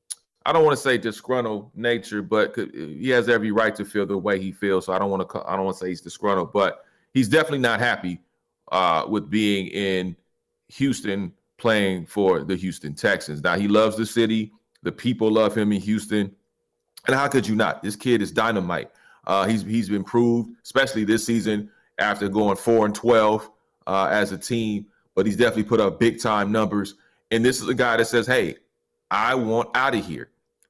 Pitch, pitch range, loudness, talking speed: 110 Hz, 100-115 Hz, -22 LUFS, 200 wpm